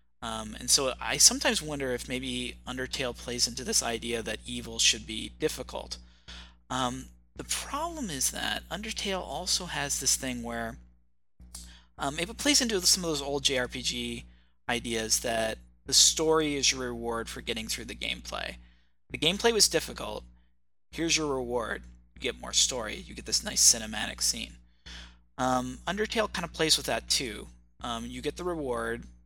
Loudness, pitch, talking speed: -28 LUFS, 120 Hz, 165 wpm